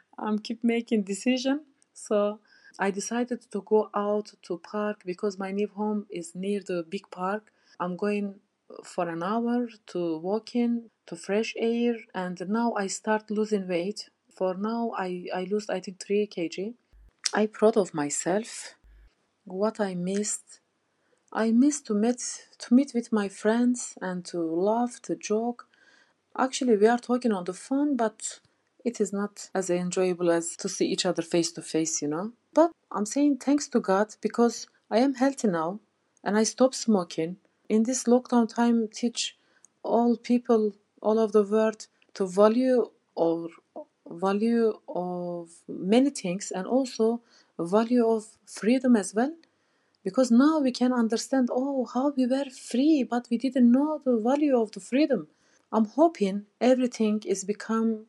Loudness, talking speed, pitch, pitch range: -27 LUFS, 160 wpm, 215 Hz, 195-240 Hz